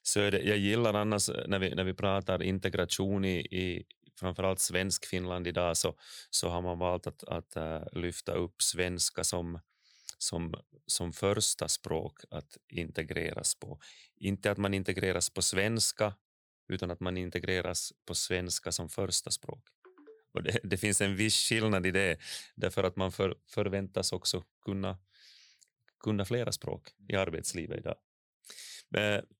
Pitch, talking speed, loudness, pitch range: 95 Hz, 150 wpm, -32 LUFS, 90-105 Hz